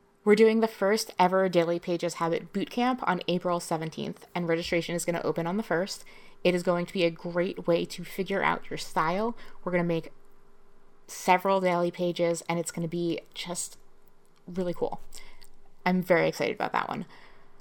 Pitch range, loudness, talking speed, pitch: 170-200 Hz, -28 LUFS, 185 wpm, 180 Hz